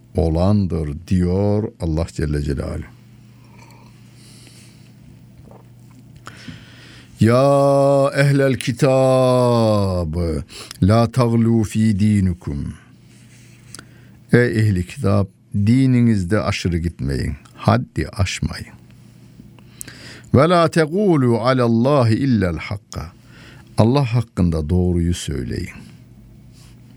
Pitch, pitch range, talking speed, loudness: 115 Hz, 95-125 Hz, 65 wpm, -18 LUFS